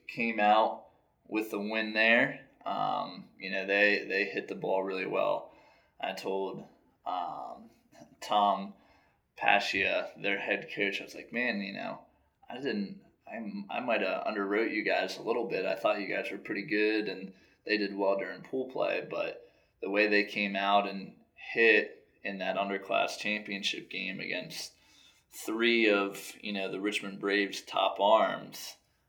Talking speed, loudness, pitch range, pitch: 165 wpm, -30 LUFS, 100-110 Hz, 105 Hz